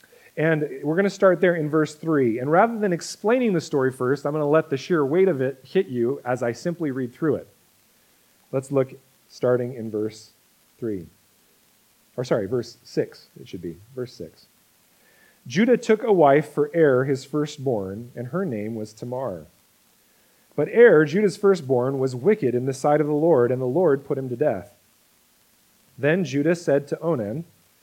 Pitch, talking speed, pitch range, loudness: 140 Hz, 185 wpm, 125-165 Hz, -22 LUFS